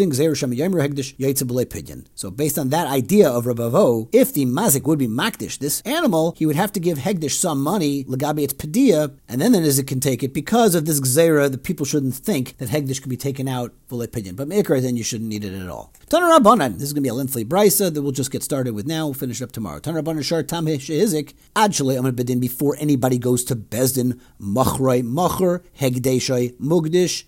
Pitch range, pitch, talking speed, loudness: 125-160 Hz, 140 Hz, 200 wpm, -20 LUFS